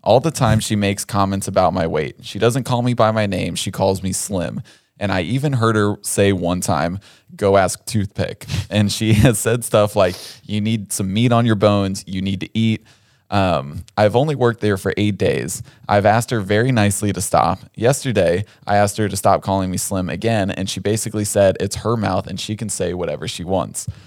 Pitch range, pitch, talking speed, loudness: 95-115 Hz, 105 Hz, 215 wpm, -18 LUFS